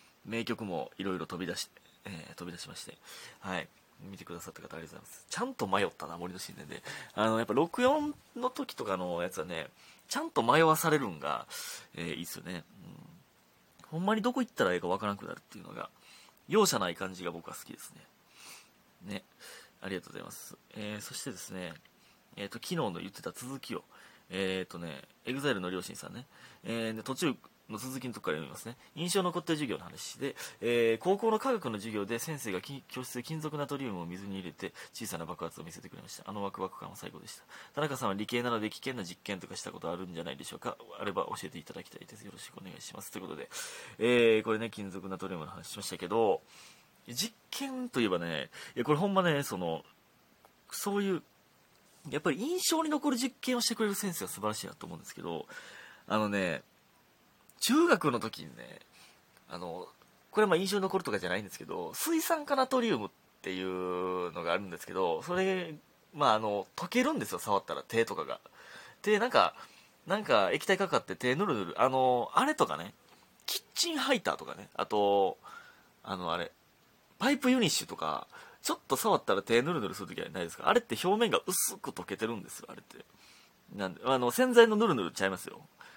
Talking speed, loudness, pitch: 410 characters per minute, -33 LUFS, 125 Hz